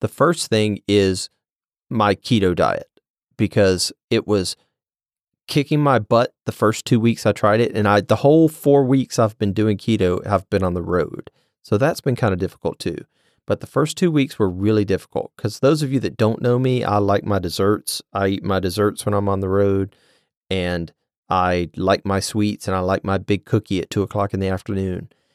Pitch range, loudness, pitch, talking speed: 95-115 Hz, -20 LUFS, 105 Hz, 210 wpm